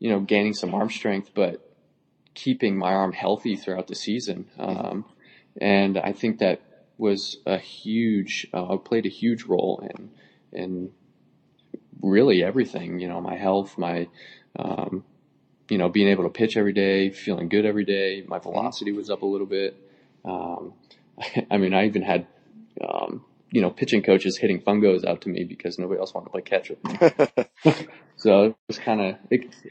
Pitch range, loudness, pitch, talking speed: 95-105 Hz, -24 LUFS, 100 Hz, 175 wpm